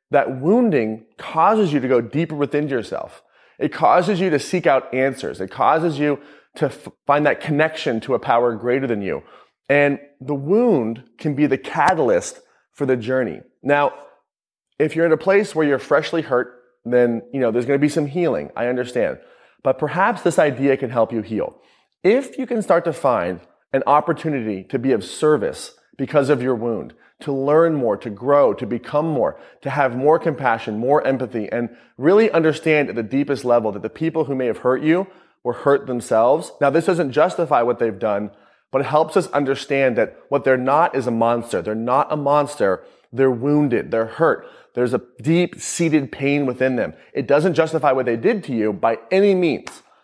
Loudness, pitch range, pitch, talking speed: -19 LUFS, 125-160 Hz, 140 Hz, 195 wpm